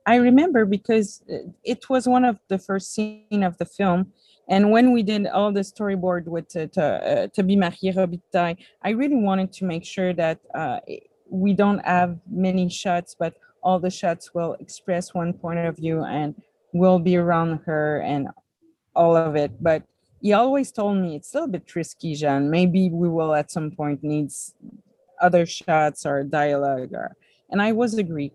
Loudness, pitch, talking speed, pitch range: -22 LUFS, 185 Hz, 185 wpm, 165-210 Hz